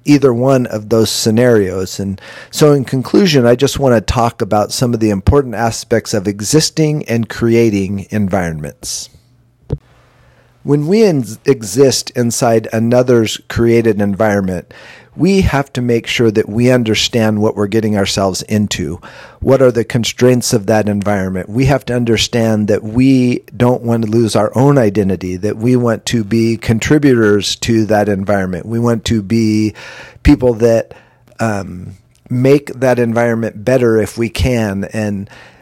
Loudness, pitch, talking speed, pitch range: -13 LUFS, 115 Hz, 150 wpm, 105-125 Hz